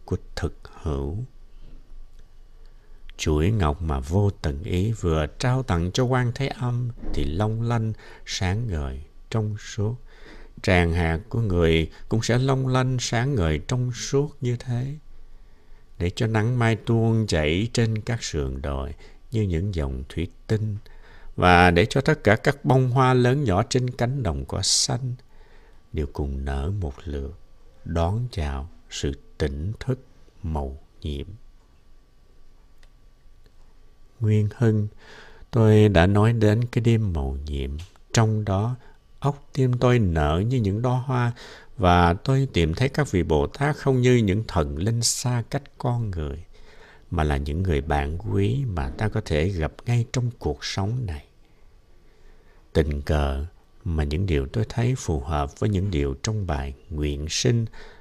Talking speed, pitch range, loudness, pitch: 155 wpm, 80-120 Hz, -24 LUFS, 100 Hz